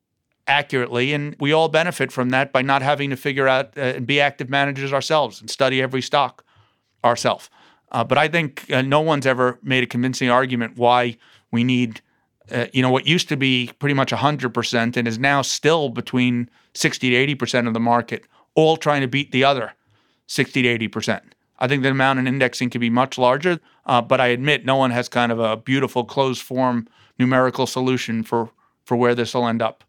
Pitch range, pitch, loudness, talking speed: 120-140 Hz, 130 Hz, -20 LUFS, 200 wpm